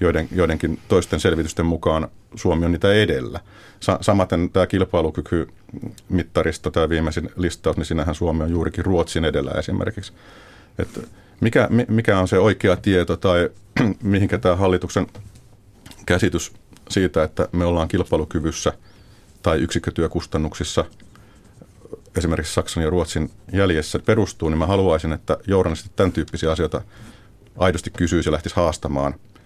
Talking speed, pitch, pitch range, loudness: 130 wpm, 90 Hz, 80-100 Hz, -21 LUFS